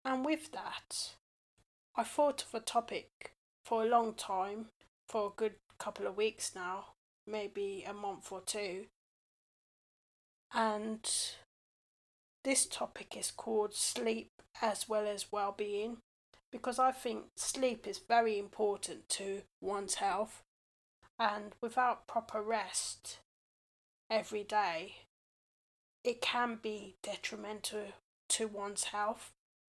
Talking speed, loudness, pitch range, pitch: 115 wpm, -37 LUFS, 205-235 Hz, 215 Hz